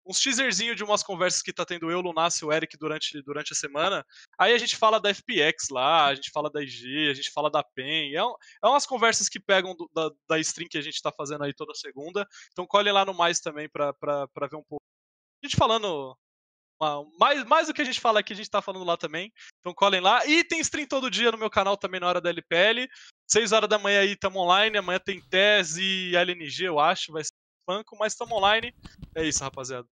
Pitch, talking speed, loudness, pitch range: 180 Hz, 245 wpm, -25 LUFS, 150-210 Hz